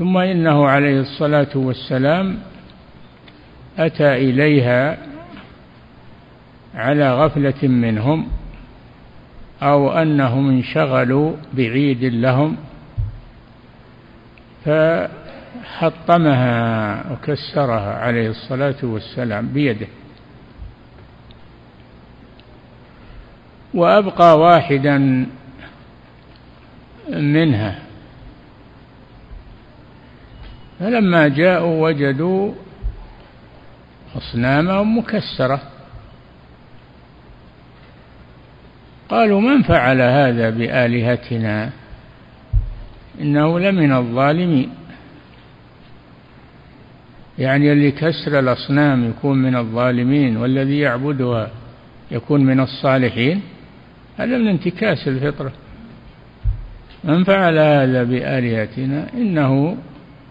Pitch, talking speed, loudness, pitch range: 135 Hz, 60 wpm, -17 LUFS, 120-150 Hz